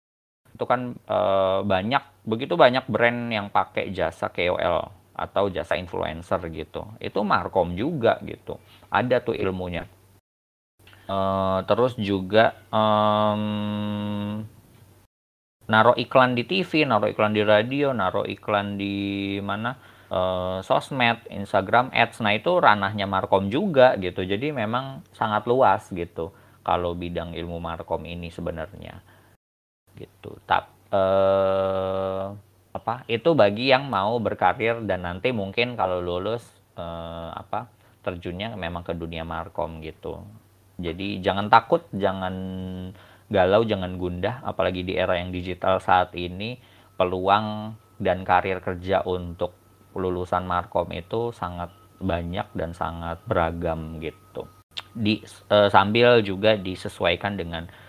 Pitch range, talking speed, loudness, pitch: 90-110 Hz, 115 wpm, -24 LUFS, 95 Hz